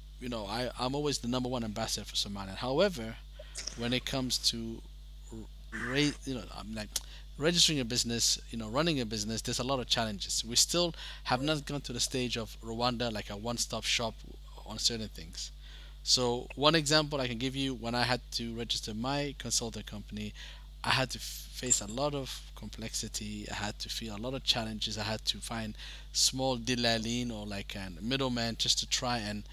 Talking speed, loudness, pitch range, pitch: 195 wpm, -32 LUFS, 105-130 Hz, 115 Hz